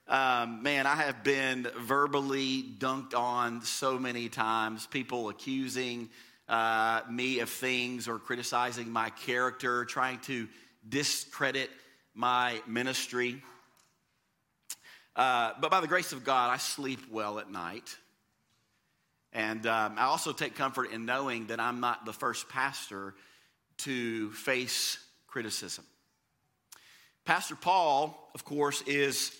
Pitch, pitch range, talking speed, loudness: 125 Hz, 115-135 Hz, 120 wpm, -32 LUFS